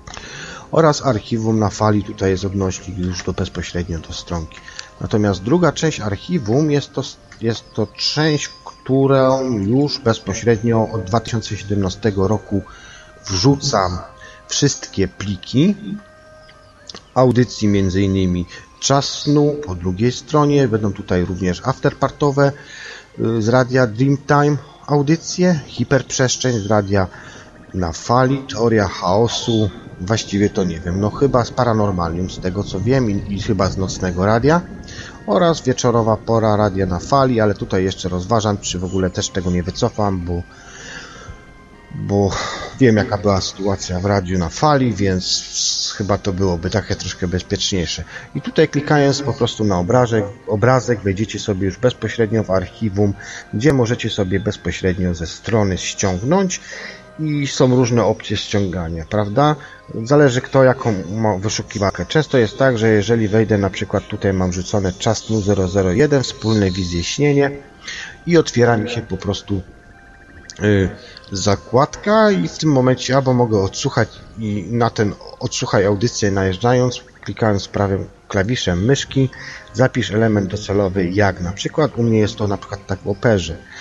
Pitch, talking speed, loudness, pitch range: 105 Hz, 135 wpm, -18 LUFS, 95-130 Hz